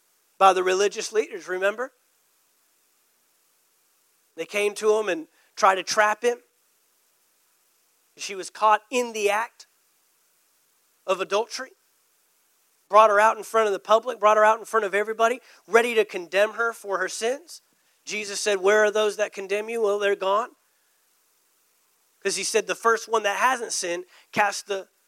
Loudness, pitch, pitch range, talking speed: -23 LUFS, 210 Hz, 195-225 Hz, 160 wpm